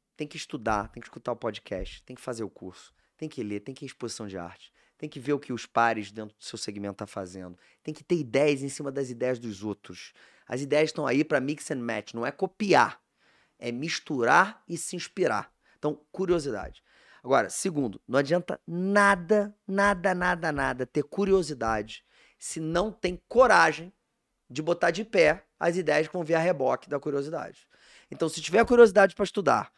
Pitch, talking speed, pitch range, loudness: 150 Hz, 200 wpm, 120-180 Hz, -27 LUFS